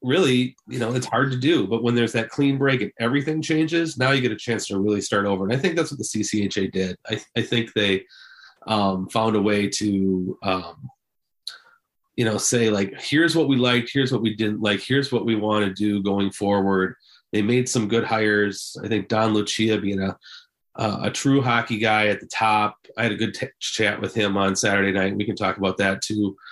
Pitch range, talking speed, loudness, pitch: 100-120 Hz, 225 wpm, -22 LUFS, 110 Hz